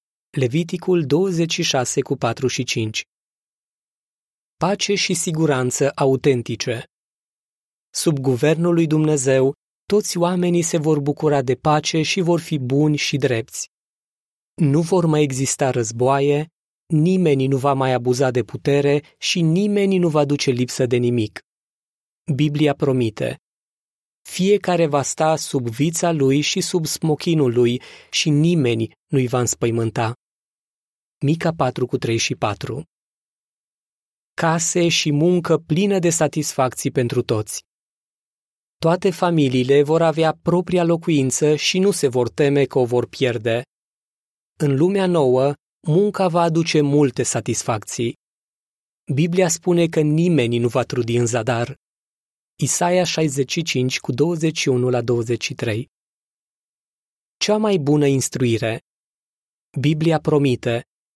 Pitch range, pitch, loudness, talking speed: 130-170 Hz, 145 Hz, -19 LUFS, 115 wpm